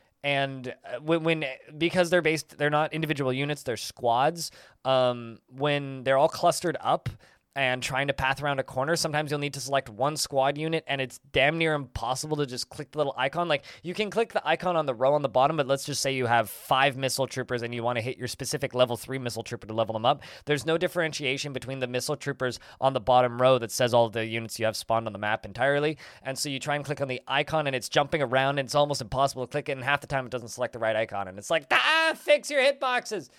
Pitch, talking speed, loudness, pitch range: 135 Hz, 250 wpm, -27 LUFS, 125-150 Hz